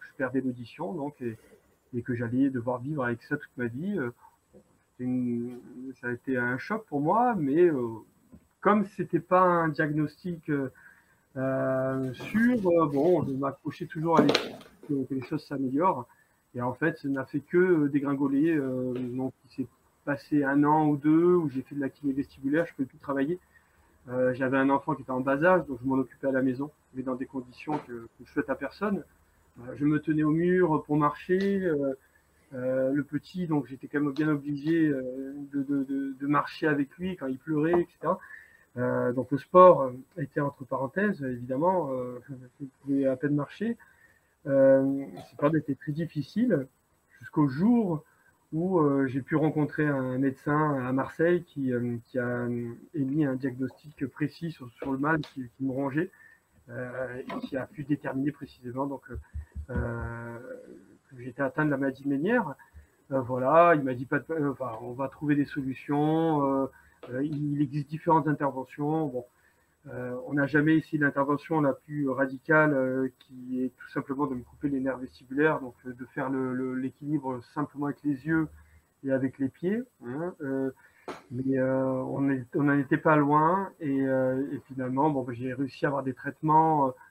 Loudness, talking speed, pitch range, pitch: -28 LUFS, 175 wpm, 130-155 Hz, 140 Hz